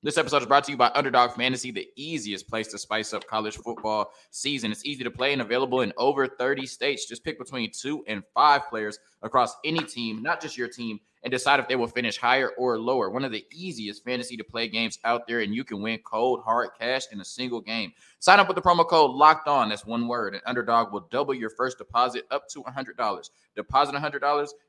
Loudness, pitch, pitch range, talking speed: -25 LUFS, 125 Hz, 115-140 Hz, 240 wpm